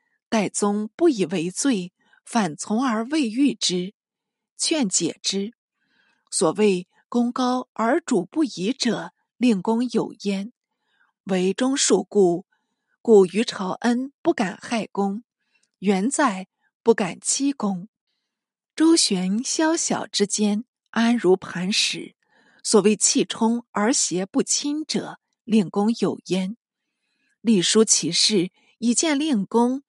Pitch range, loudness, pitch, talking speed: 200-255 Hz, -22 LUFS, 225 Hz, 155 characters per minute